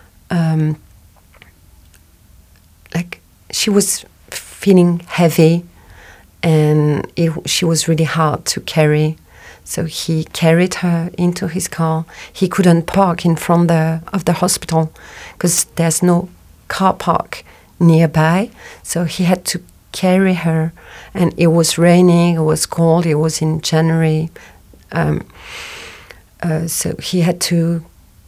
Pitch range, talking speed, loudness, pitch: 155-175 Hz, 125 wpm, -15 LUFS, 165 Hz